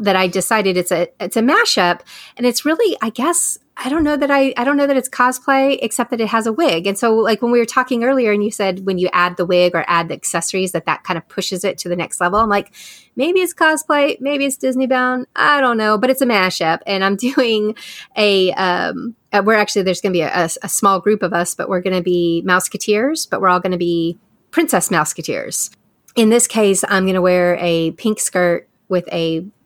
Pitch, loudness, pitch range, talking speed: 205 Hz, -16 LUFS, 180-250 Hz, 235 wpm